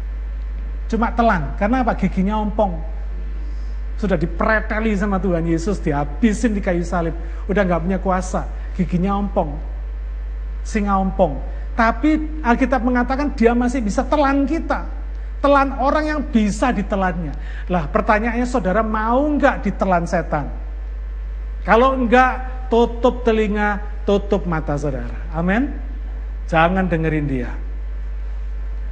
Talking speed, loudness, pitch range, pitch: 110 wpm, -20 LUFS, 150-235 Hz, 195 Hz